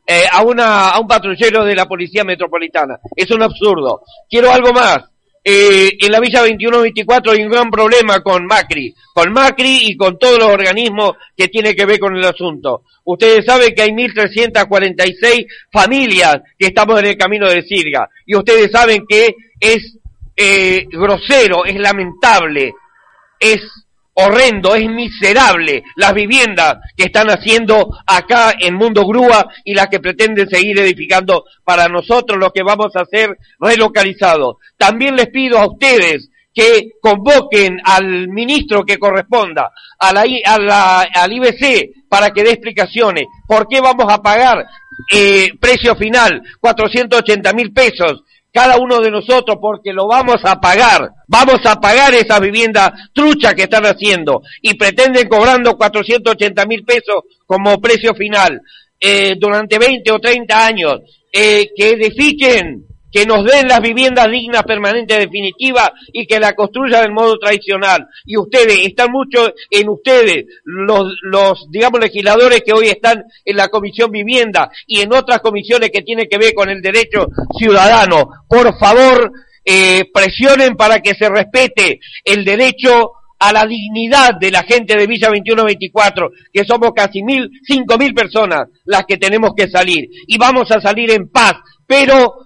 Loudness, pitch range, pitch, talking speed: -10 LUFS, 200-240 Hz, 215 Hz, 155 wpm